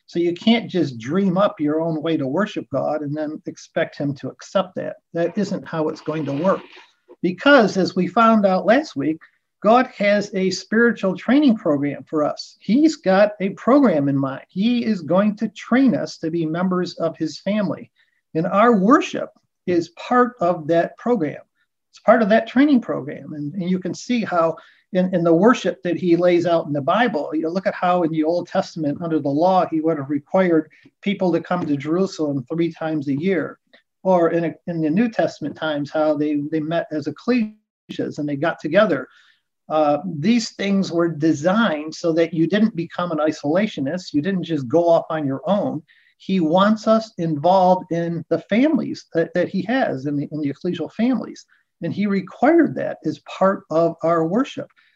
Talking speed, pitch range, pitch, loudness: 195 wpm, 160-210 Hz, 175 Hz, -20 LUFS